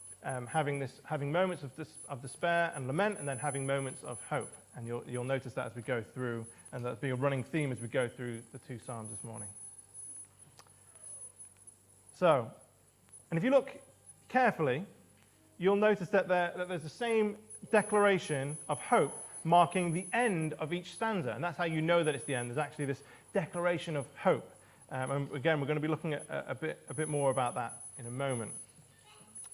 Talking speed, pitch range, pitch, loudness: 200 wpm, 120-170 Hz, 140 Hz, -34 LUFS